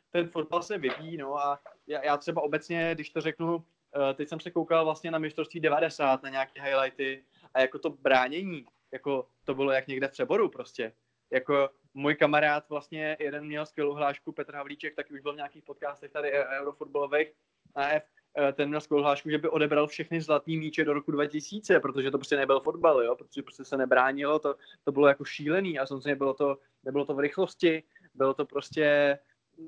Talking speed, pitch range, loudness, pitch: 190 wpm, 140-160 Hz, -29 LUFS, 145 Hz